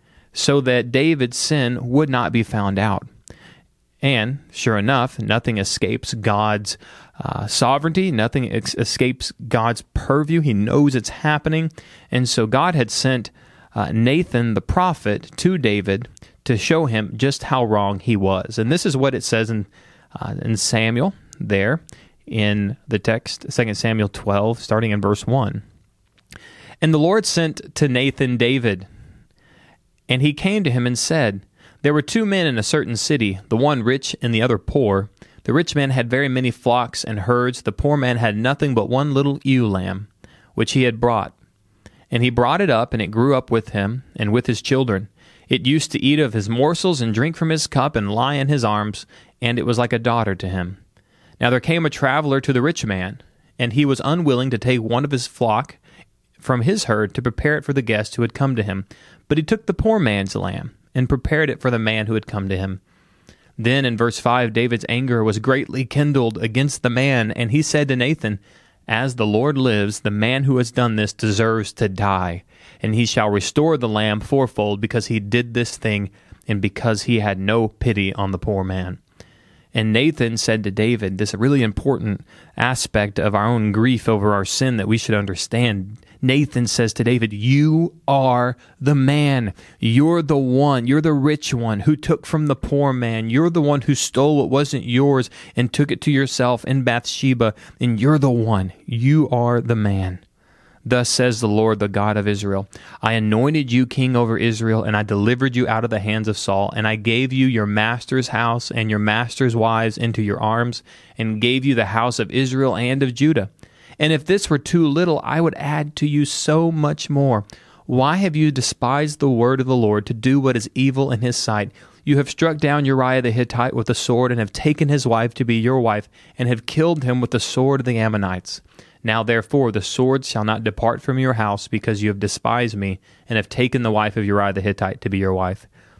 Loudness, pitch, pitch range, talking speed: -19 LUFS, 120 Hz, 110-135 Hz, 205 wpm